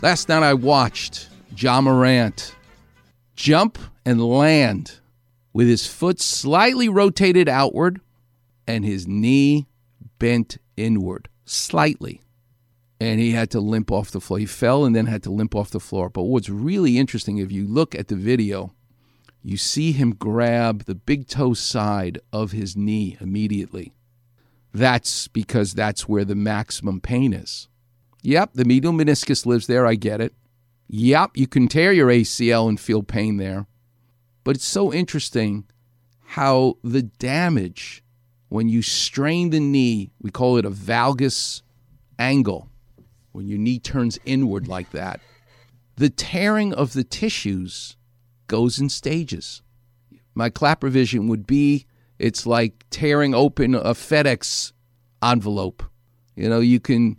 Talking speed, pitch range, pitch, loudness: 145 wpm, 110-135 Hz, 120 Hz, -20 LUFS